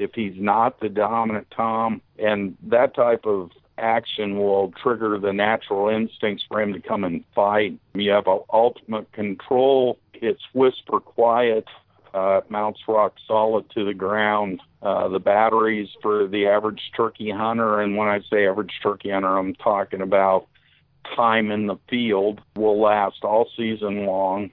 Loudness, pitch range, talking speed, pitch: -22 LUFS, 100-110 Hz, 155 wpm, 105 Hz